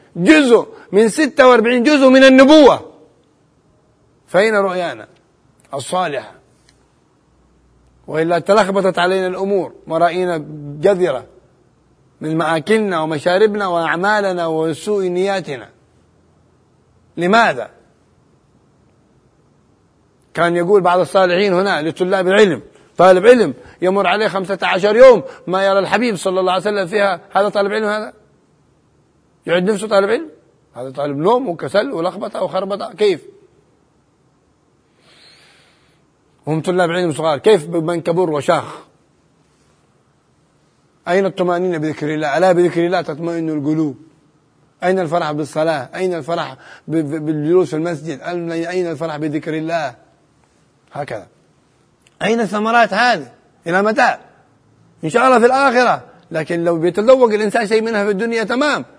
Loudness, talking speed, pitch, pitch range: -15 LUFS, 110 wpm, 180 Hz, 160-210 Hz